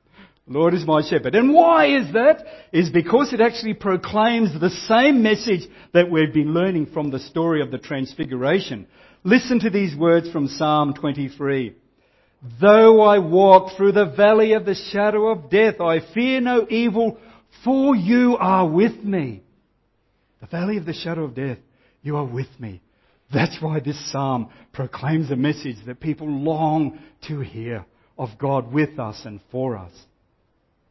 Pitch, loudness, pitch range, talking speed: 165 Hz, -19 LUFS, 140-210 Hz, 160 wpm